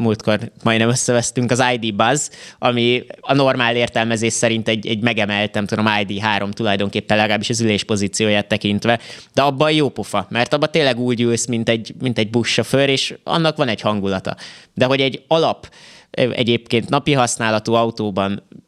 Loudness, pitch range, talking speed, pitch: -18 LUFS, 105-125 Hz, 155 wpm, 115 Hz